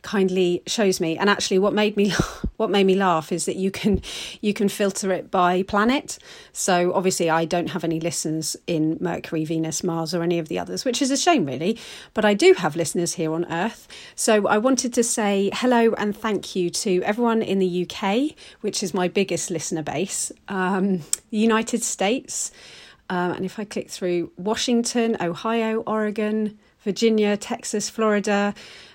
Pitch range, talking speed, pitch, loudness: 175-220 Hz, 180 wpm, 195 Hz, -22 LUFS